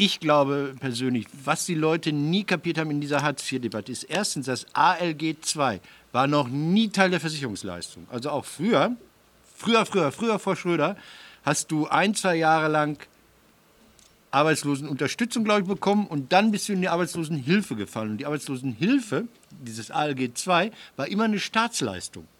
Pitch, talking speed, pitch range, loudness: 160 Hz, 160 wpm, 140-195 Hz, -25 LUFS